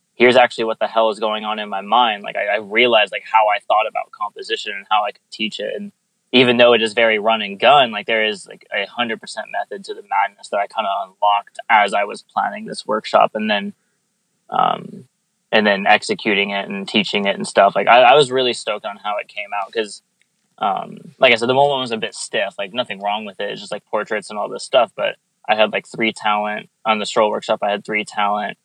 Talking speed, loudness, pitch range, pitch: 250 wpm, -18 LUFS, 105-150 Hz, 115 Hz